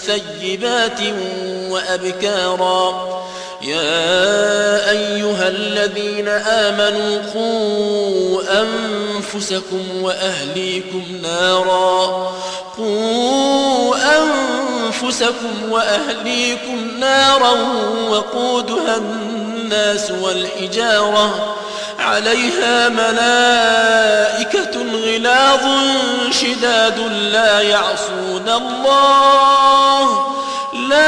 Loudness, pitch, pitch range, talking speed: -15 LUFS, 215 Hz, 195-240 Hz, 45 wpm